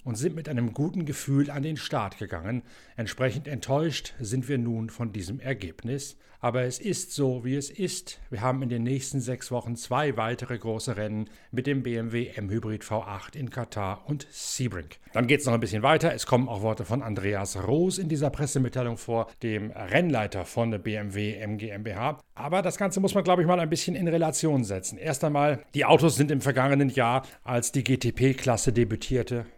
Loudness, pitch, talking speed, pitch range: -28 LUFS, 125 Hz, 190 wpm, 115-145 Hz